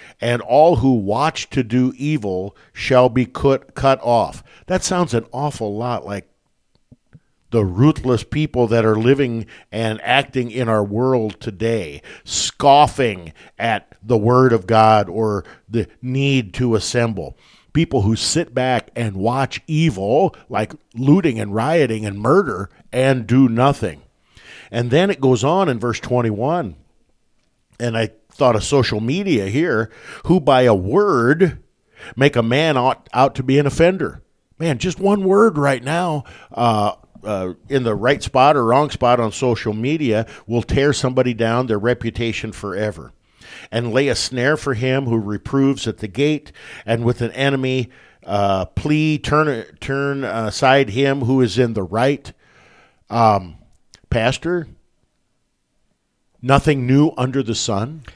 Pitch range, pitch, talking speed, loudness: 110-140 Hz, 125 Hz, 145 wpm, -18 LUFS